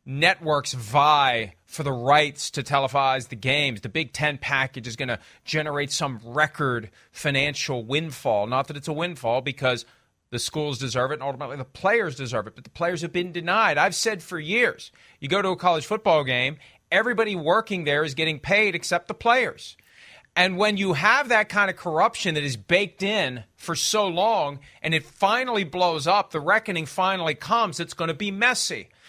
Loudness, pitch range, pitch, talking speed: -23 LUFS, 135-190 Hz, 155 Hz, 190 wpm